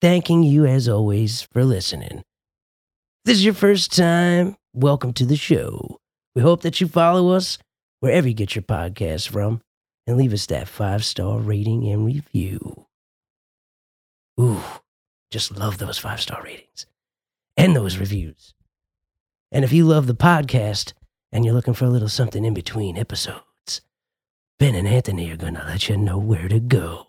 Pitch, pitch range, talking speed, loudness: 115 Hz, 100-140 Hz, 165 wpm, -20 LUFS